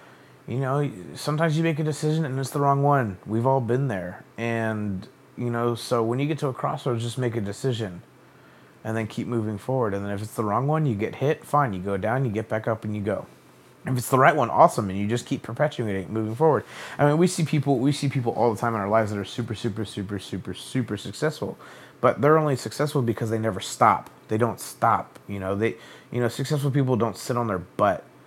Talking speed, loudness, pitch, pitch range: 240 wpm, -25 LUFS, 120 Hz, 110-140 Hz